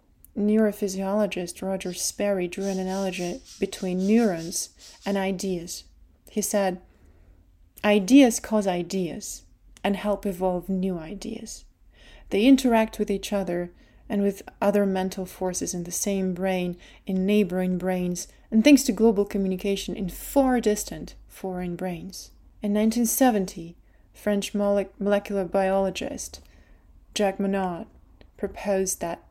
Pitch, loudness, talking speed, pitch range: 195 Hz, -25 LUFS, 115 wpm, 185-210 Hz